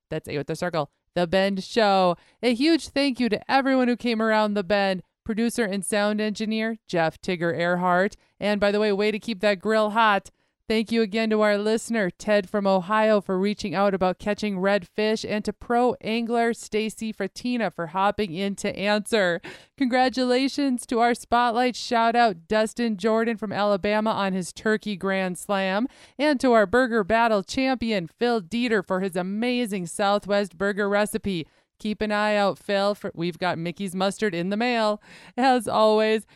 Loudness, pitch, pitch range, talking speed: -24 LUFS, 210 Hz, 195-230 Hz, 175 wpm